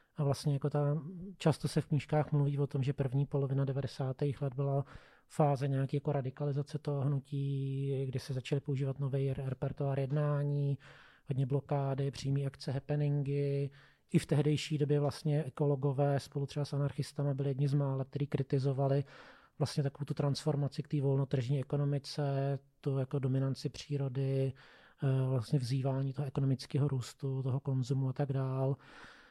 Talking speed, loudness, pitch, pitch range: 150 wpm, -35 LUFS, 140 Hz, 135-145 Hz